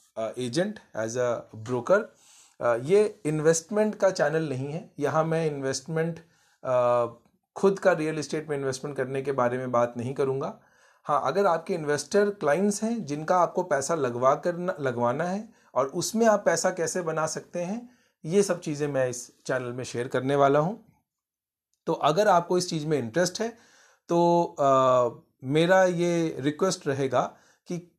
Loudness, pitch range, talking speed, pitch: -26 LUFS, 135-185 Hz, 160 wpm, 160 Hz